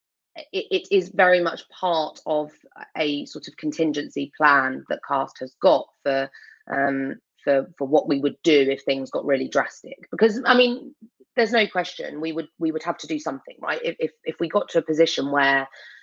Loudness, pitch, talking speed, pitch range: -23 LUFS, 160 Hz, 190 wpm, 140-180 Hz